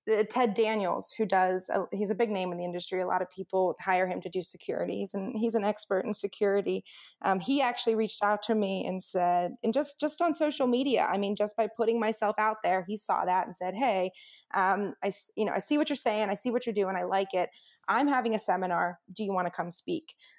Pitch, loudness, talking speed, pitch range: 205 Hz, -30 LUFS, 235 wpm, 185-230 Hz